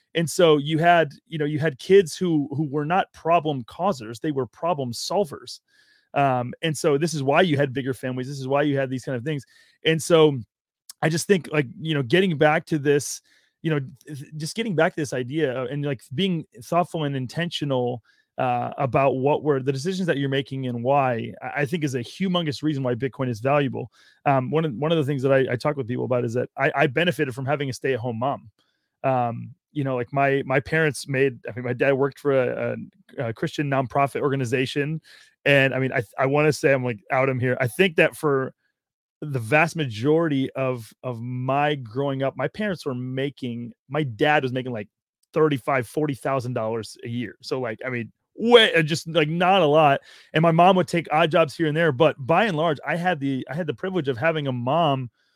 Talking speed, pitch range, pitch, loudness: 225 wpm, 130-160 Hz, 145 Hz, -23 LUFS